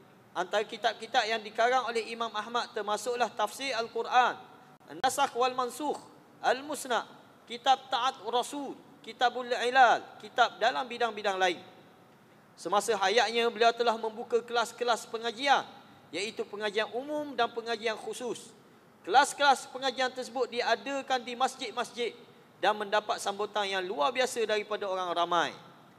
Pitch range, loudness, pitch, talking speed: 210-260 Hz, -30 LUFS, 235 Hz, 120 wpm